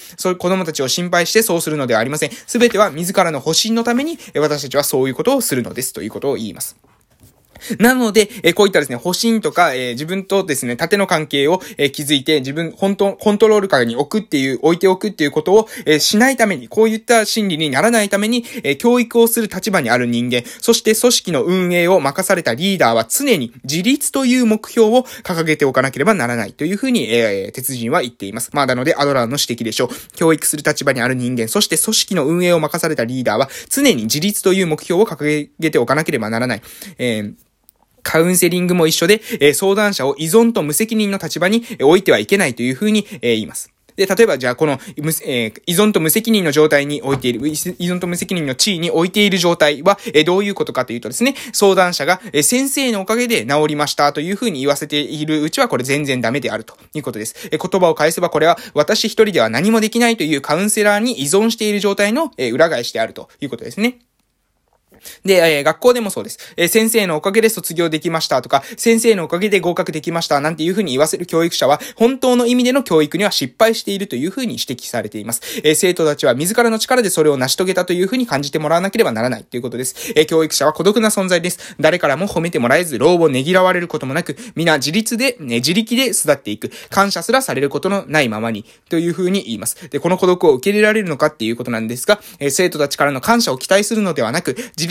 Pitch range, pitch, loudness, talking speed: 150-215 Hz, 180 Hz, -16 LUFS, 475 characters per minute